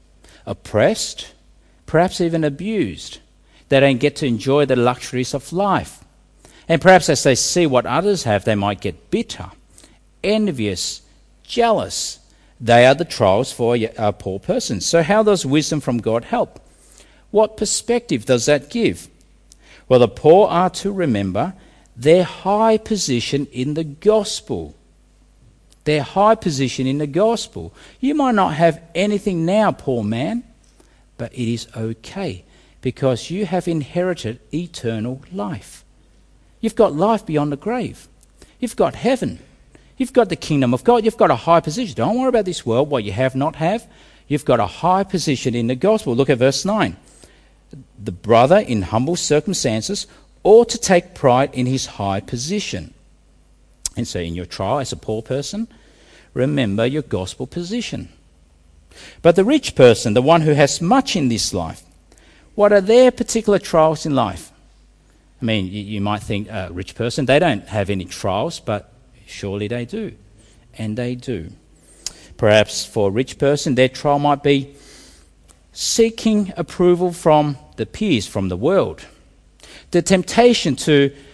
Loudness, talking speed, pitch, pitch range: -18 LUFS, 155 wpm, 140 Hz, 110-180 Hz